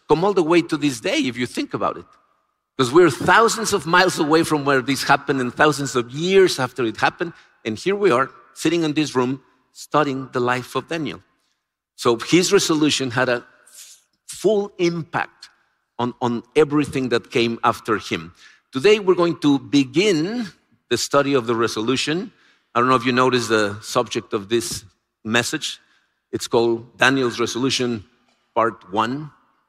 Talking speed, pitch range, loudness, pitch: 170 wpm, 120-160 Hz, -20 LUFS, 135 Hz